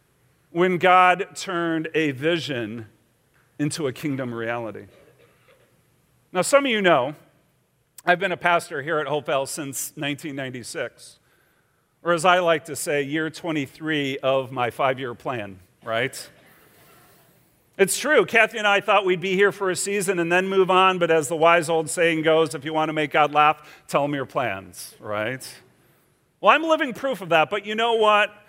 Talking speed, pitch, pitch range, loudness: 175 wpm, 160 Hz, 135-185 Hz, -22 LUFS